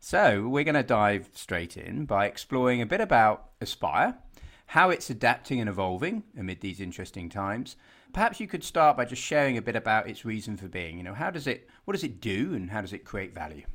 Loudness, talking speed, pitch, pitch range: -28 LUFS, 225 wpm, 110 Hz, 95-135 Hz